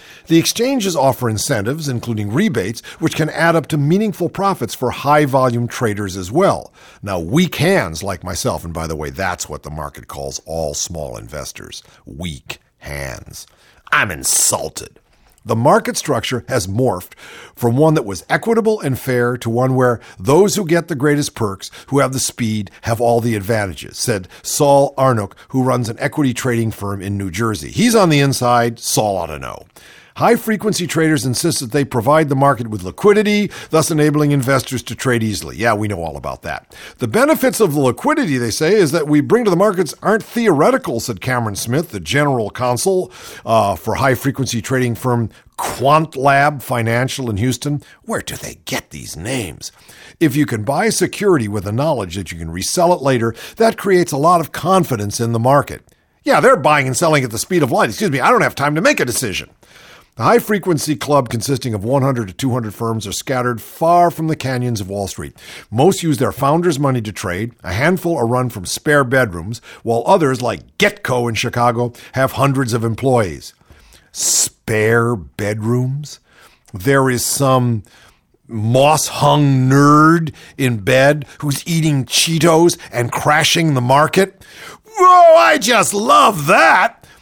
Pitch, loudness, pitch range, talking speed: 130 Hz, -16 LUFS, 115-160 Hz, 180 wpm